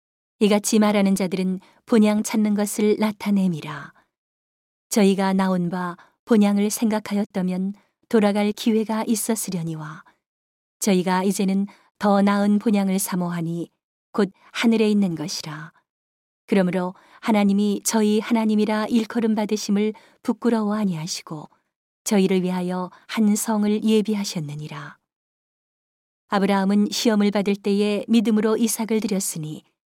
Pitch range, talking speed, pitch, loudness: 190-220 Hz, 285 characters per minute, 205 Hz, -22 LUFS